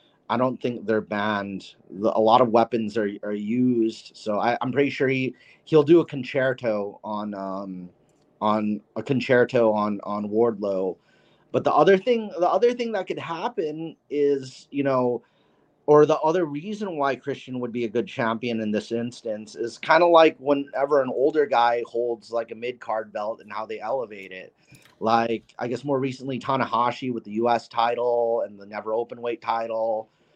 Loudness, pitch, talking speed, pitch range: -24 LUFS, 120 Hz, 180 wpm, 110-140 Hz